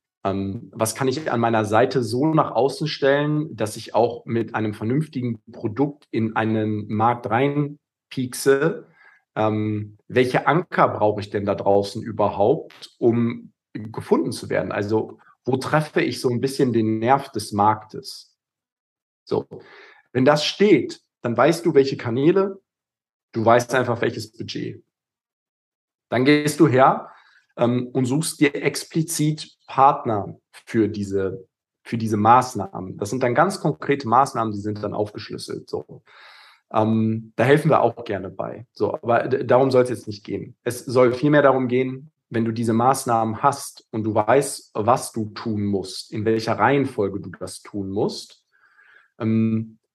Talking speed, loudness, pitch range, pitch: 150 wpm, -21 LUFS, 110-135 Hz, 120 Hz